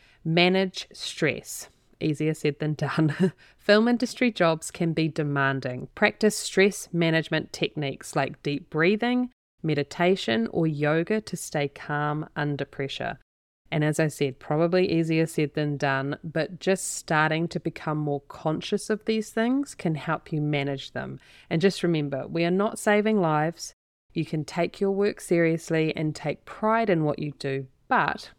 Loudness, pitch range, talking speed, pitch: -26 LUFS, 150-185 Hz, 155 wpm, 160 Hz